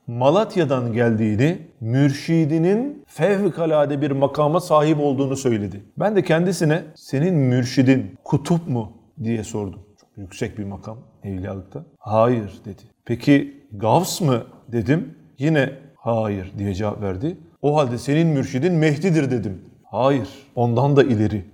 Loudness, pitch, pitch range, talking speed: -20 LUFS, 135 Hz, 110-155 Hz, 125 wpm